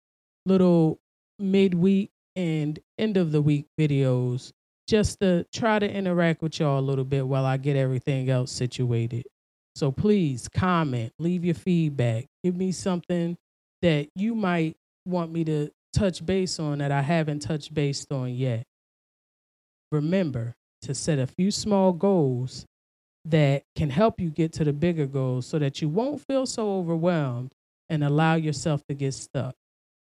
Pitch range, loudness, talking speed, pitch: 135-180 Hz, -25 LUFS, 155 wpm, 155 Hz